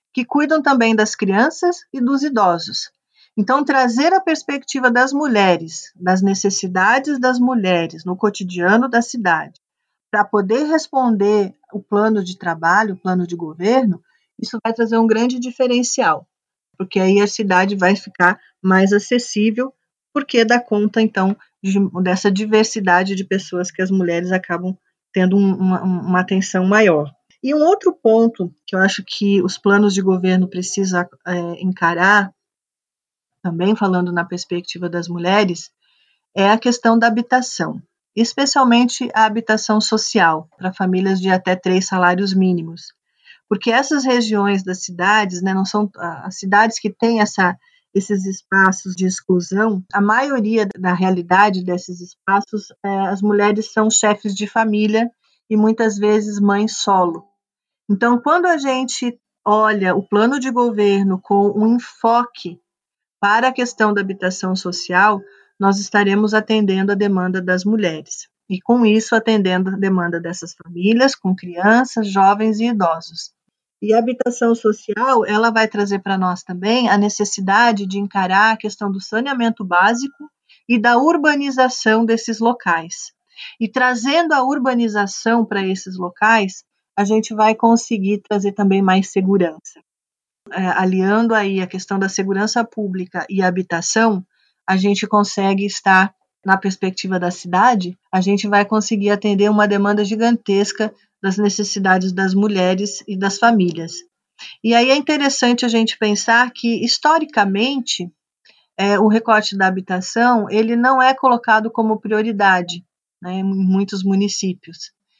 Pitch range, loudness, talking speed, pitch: 190-230 Hz, -17 LUFS, 140 wpm, 205 Hz